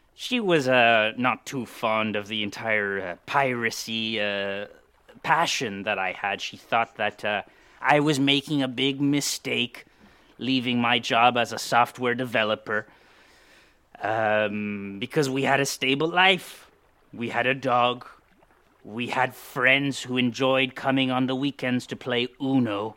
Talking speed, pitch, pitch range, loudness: 145 wpm, 125 Hz, 110-135 Hz, -24 LUFS